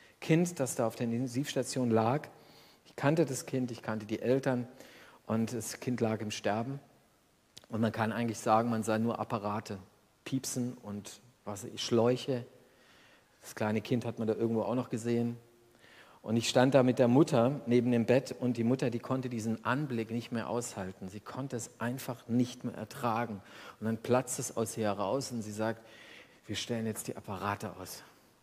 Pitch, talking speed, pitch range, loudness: 120 Hz, 180 wpm, 110-125 Hz, -33 LUFS